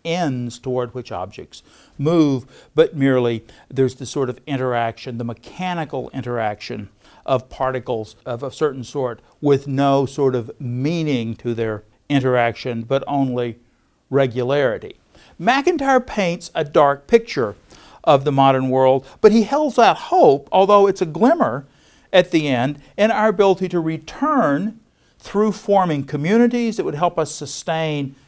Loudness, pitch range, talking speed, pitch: -19 LUFS, 125-180 Hz, 140 wpm, 140 Hz